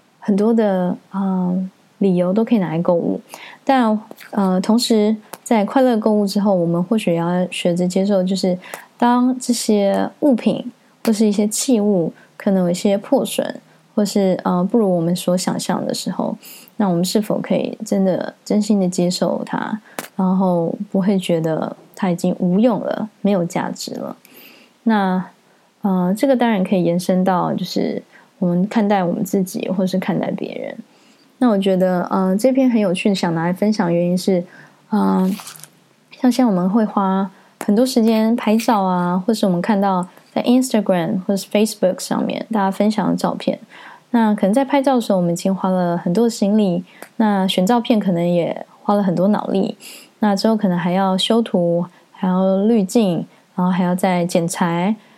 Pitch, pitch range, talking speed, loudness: 200 Hz, 185-225 Hz, 270 characters per minute, -18 LUFS